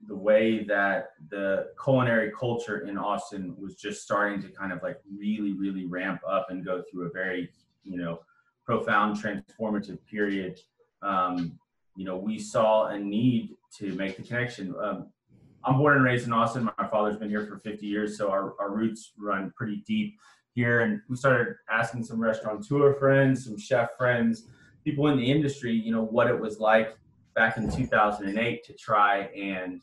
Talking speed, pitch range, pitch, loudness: 180 wpm, 100-120 Hz, 105 Hz, -27 LUFS